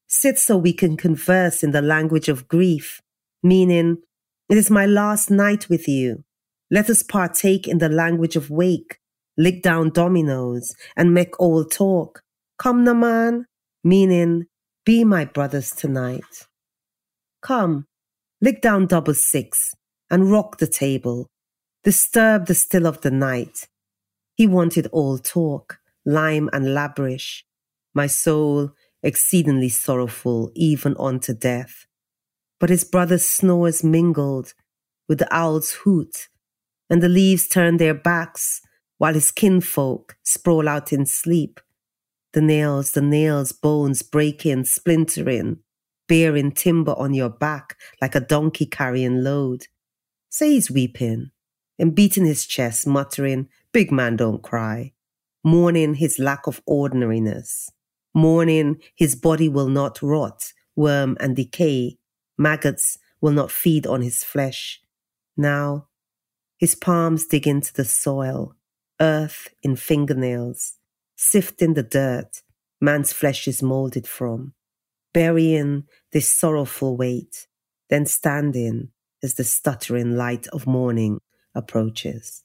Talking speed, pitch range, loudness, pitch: 125 wpm, 130-170 Hz, -19 LUFS, 150 Hz